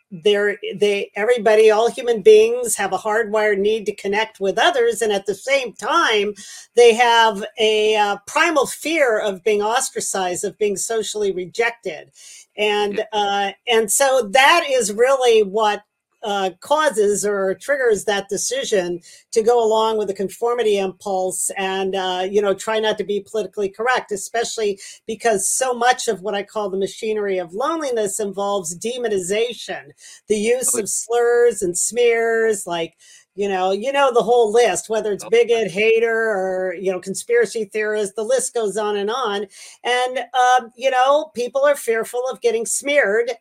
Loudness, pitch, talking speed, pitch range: -18 LUFS, 215 Hz, 160 wpm, 200-240 Hz